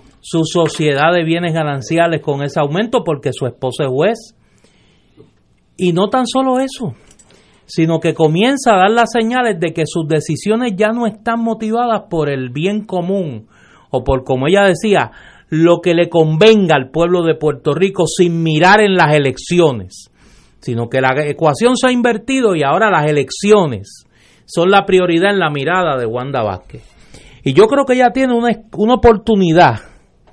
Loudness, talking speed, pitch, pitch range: -14 LUFS, 170 wpm, 175 Hz, 150-215 Hz